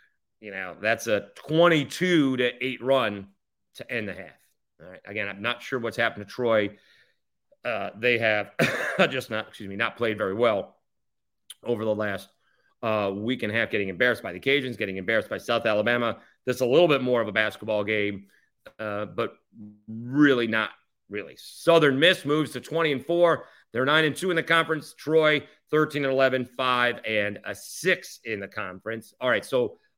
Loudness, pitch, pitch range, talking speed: -25 LUFS, 120 Hz, 105-145 Hz, 190 wpm